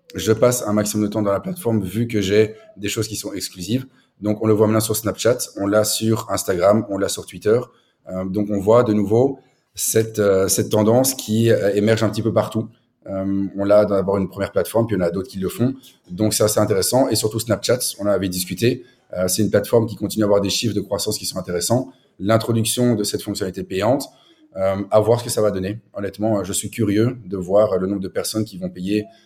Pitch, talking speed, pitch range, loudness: 105 Hz, 240 wpm, 100-110 Hz, -20 LUFS